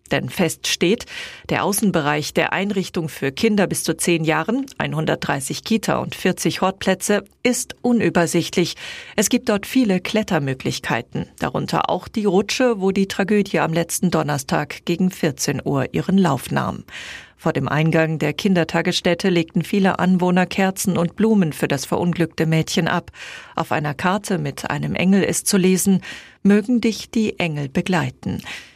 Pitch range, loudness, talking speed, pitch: 160-200 Hz, -20 LUFS, 150 wpm, 180 Hz